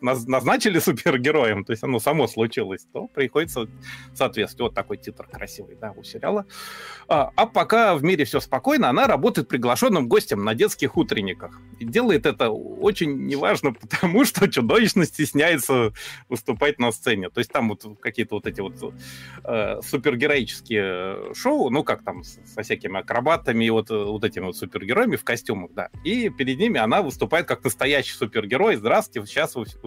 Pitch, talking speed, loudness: 135 Hz, 160 wpm, -22 LUFS